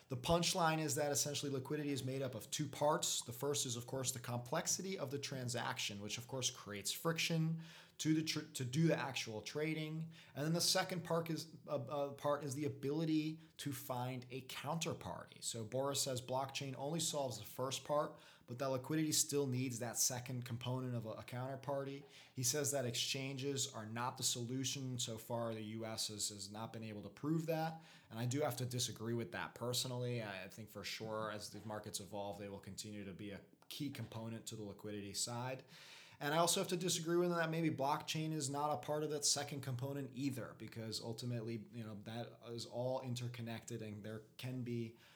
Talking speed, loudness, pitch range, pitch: 200 wpm, -41 LUFS, 115-150 Hz, 130 Hz